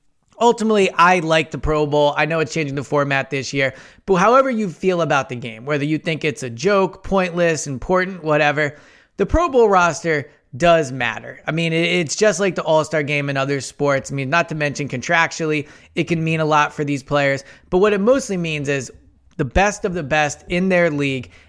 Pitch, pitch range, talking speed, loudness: 155 Hz, 145-180 Hz, 210 wpm, -18 LUFS